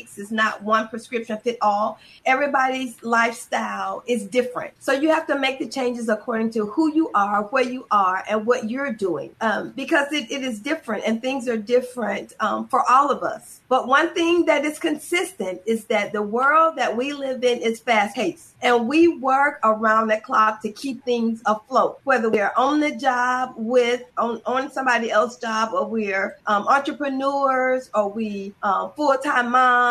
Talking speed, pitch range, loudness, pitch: 180 wpm, 220-275 Hz, -21 LUFS, 245 Hz